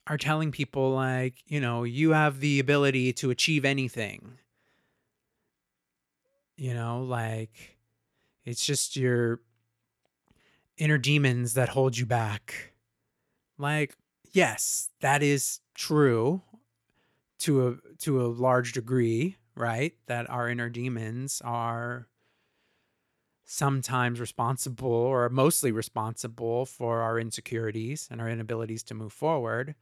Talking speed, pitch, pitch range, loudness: 115 wpm, 125 Hz, 115-140 Hz, -28 LUFS